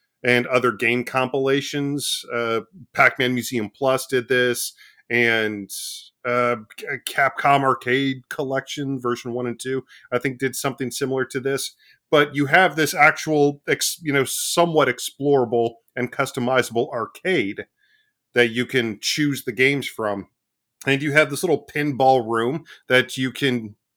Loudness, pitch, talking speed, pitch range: -21 LUFS, 130 Hz, 140 wpm, 120-140 Hz